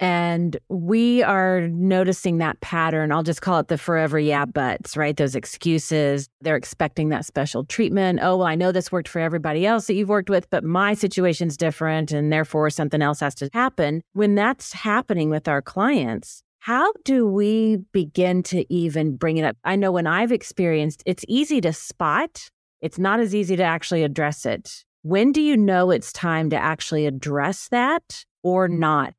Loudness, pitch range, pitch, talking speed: -21 LUFS, 155-195 Hz, 170 Hz, 185 wpm